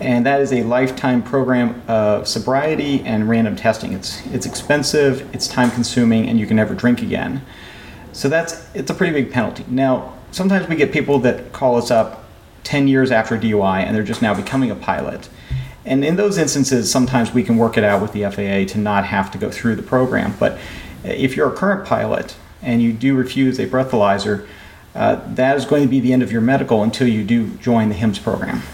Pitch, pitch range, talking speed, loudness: 125 Hz, 110-135 Hz, 210 wpm, -17 LUFS